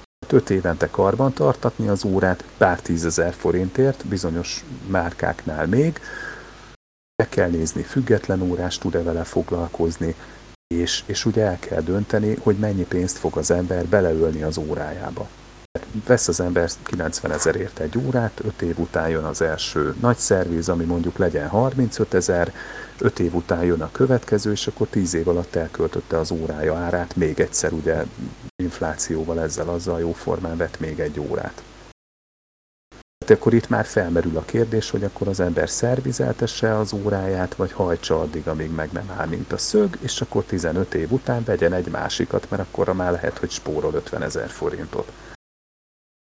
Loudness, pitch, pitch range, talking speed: -21 LUFS, 90 Hz, 85-110 Hz, 160 wpm